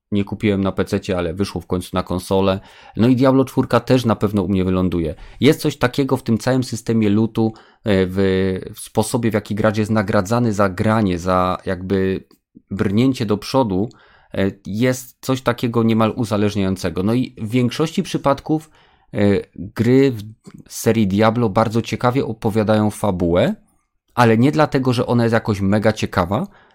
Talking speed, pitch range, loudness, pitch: 155 wpm, 95-125 Hz, -18 LUFS, 110 Hz